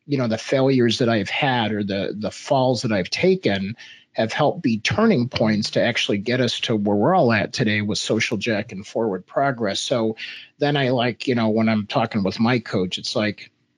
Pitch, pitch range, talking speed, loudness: 115 Hz, 105-125 Hz, 215 wpm, -21 LUFS